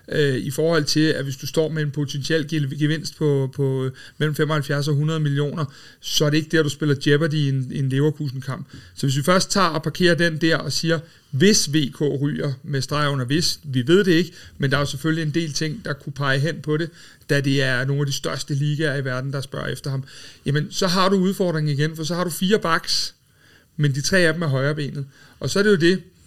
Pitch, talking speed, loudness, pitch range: 150 Hz, 240 wpm, -21 LUFS, 140-160 Hz